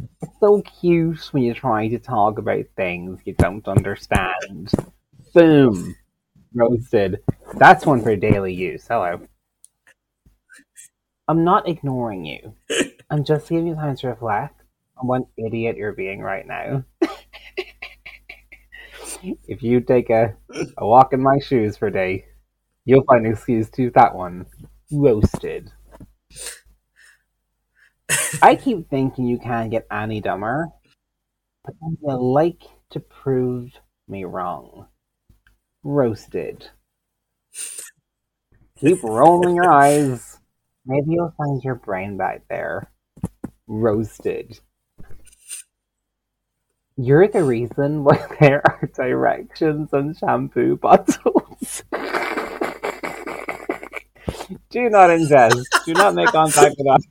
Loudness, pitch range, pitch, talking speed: -18 LUFS, 115-155 Hz, 135 Hz, 110 wpm